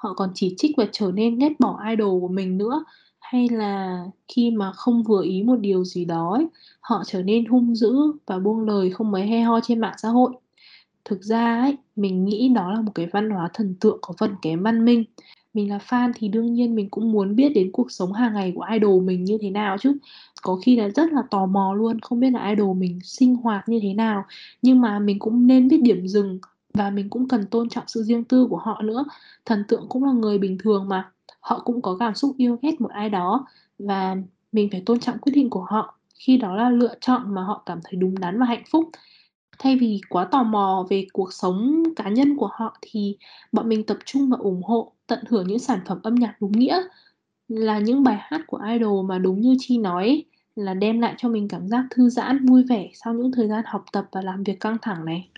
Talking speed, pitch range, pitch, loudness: 240 wpm, 195-245 Hz, 220 Hz, -22 LUFS